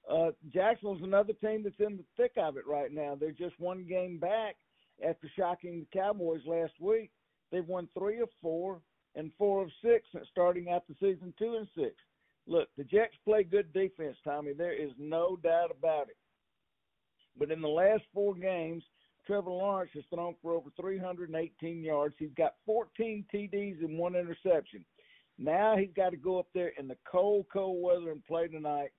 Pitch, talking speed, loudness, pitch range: 180 Hz, 180 wpm, -34 LUFS, 165-200 Hz